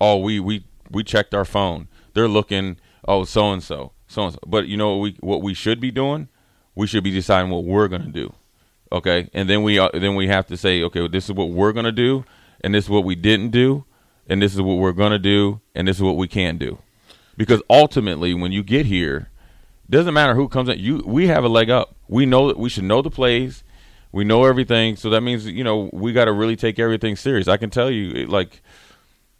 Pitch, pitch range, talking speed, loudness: 105 Hz, 95-115 Hz, 240 wpm, -19 LUFS